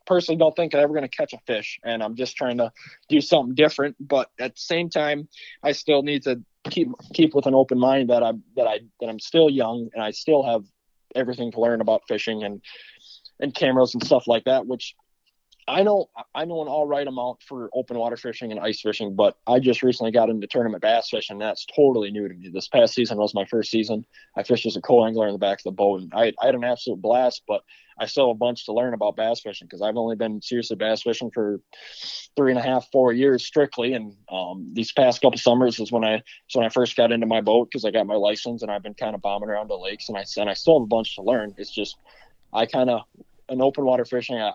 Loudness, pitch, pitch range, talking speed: -23 LUFS, 120 Hz, 110-135 Hz, 255 wpm